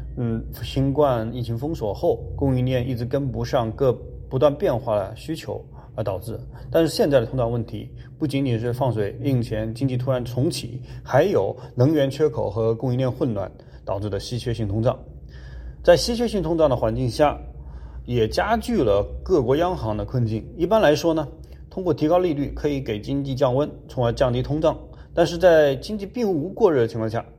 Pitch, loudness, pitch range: 125 Hz, -22 LUFS, 115-150 Hz